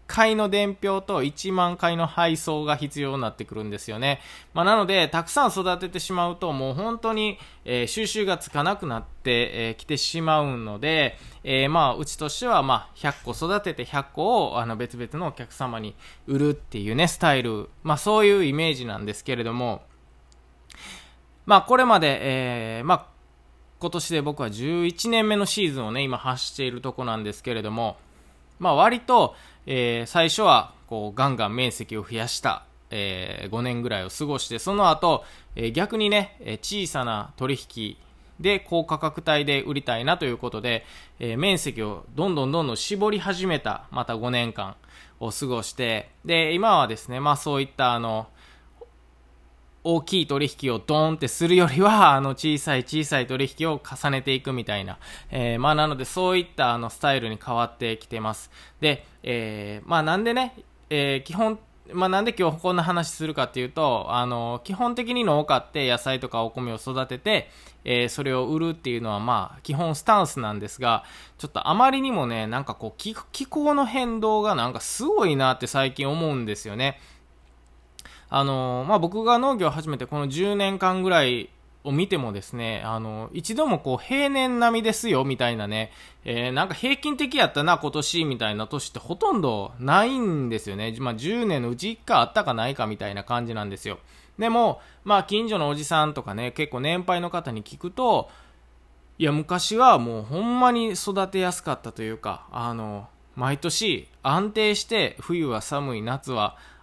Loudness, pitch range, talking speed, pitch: -24 LUFS, 115-180 Hz, 335 characters per minute, 140 Hz